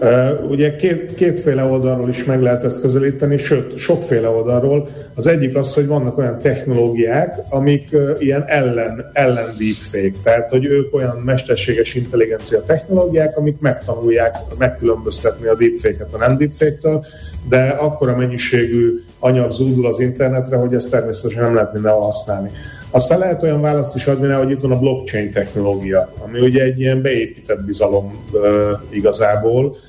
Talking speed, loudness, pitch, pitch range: 150 wpm, -16 LUFS, 130 Hz, 115-145 Hz